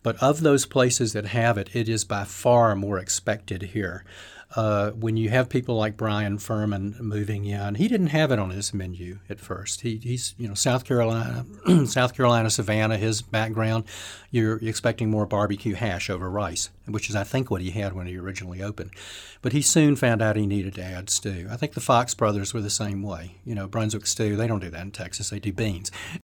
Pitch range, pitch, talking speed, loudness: 100-115 Hz, 105 Hz, 215 wpm, -25 LUFS